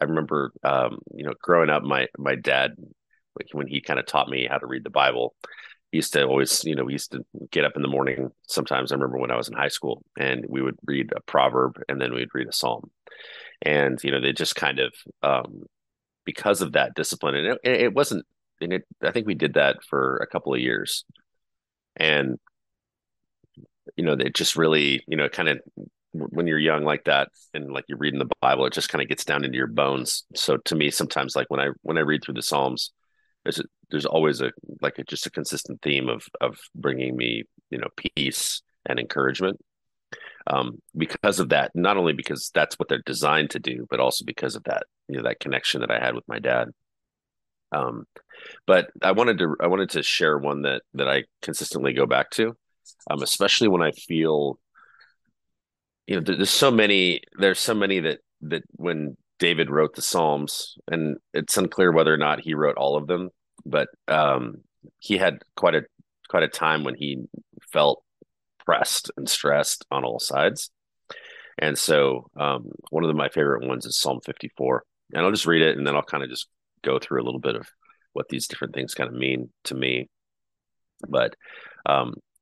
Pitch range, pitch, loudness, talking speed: 65-80 Hz, 70 Hz, -24 LUFS, 205 wpm